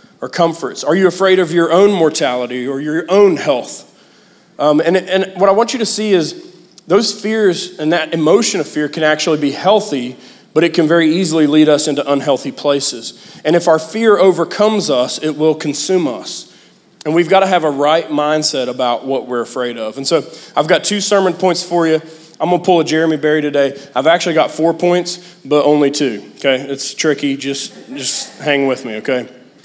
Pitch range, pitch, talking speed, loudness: 145-185 Hz, 160 Hz, 205 wpm, -14 LUFS